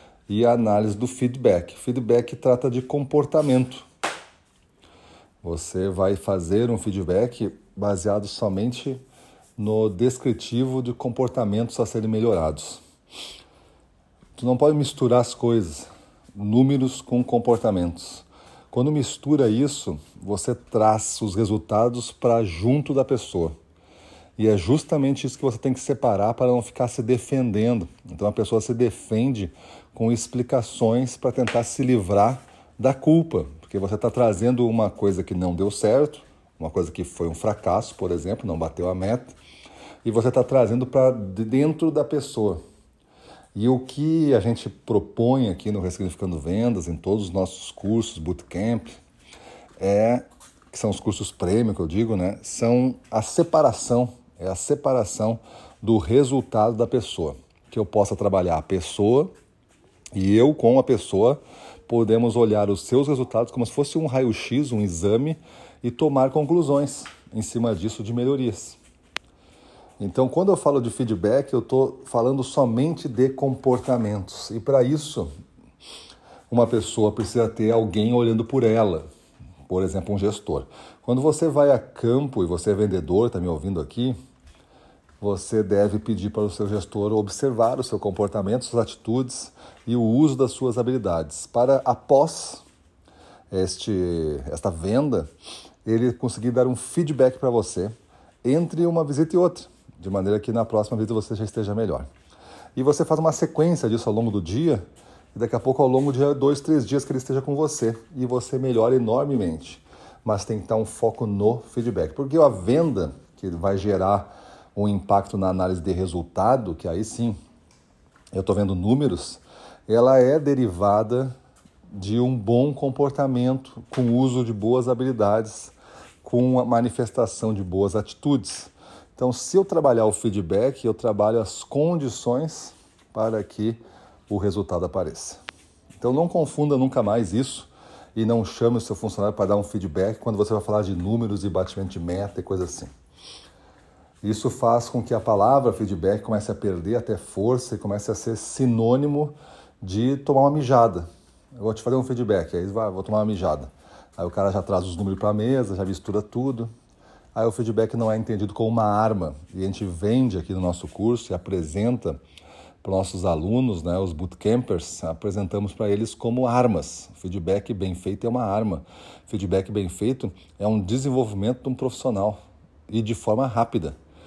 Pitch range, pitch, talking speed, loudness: 100-125 Hz, 115 Hz, 160 wpm, -23 LUFS